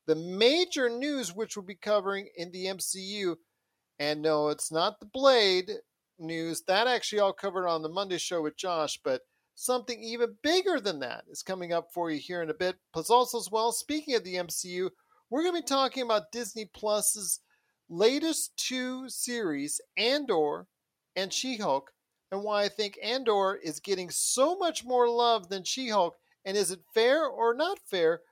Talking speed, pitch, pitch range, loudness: 180 wpm, 215 Hz, 180-260 Hz, -29 LUFS